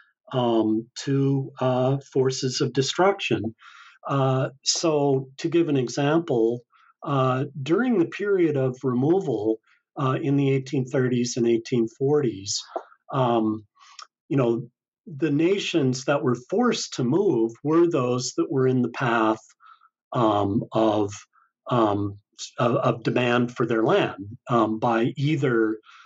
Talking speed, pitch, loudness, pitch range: 120 wpm, 130 Hz, -24 LUFS, 115-145 Hz